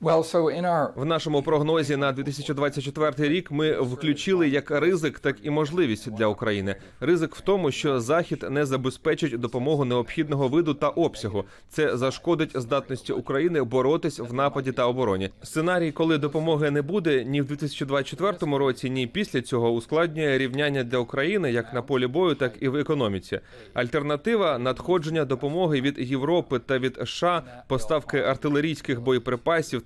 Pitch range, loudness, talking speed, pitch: 130-160 Hz, -25 LUFS, 145 wpm, 145 Hz